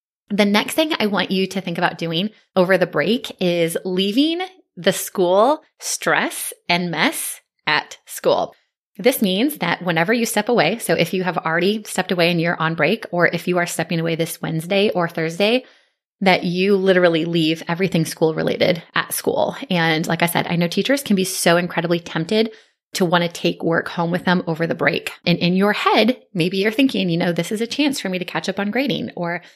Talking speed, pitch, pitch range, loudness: 210 wpm, 185 Hz, 170-210 Hz, -19 LUFS